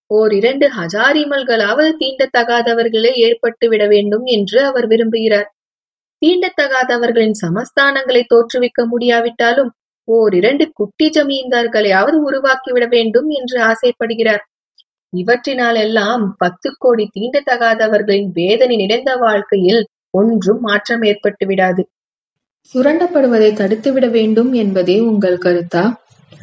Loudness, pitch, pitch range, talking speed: -13 LUFS, 230 Hz, 210-255 Hz, 85 wpm